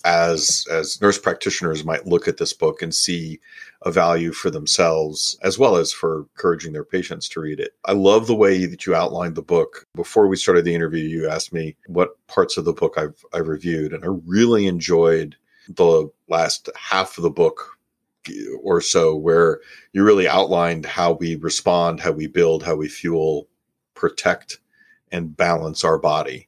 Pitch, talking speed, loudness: 90 Hz, 180 wpm, -19 LUFS